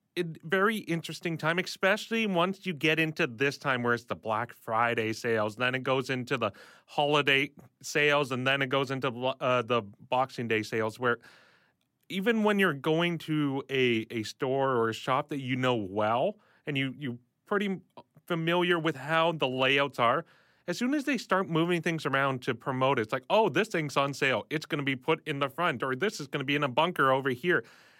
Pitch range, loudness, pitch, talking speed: 130-165 Hz, -29 LUFS, 140 Hz, 205 wpm